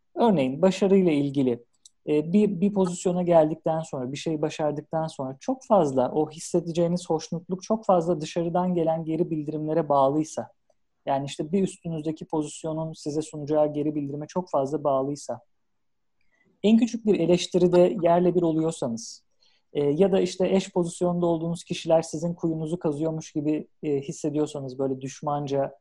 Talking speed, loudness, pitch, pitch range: 135 wpm, -25 LUFS, 160 Hz, 150-180 Hz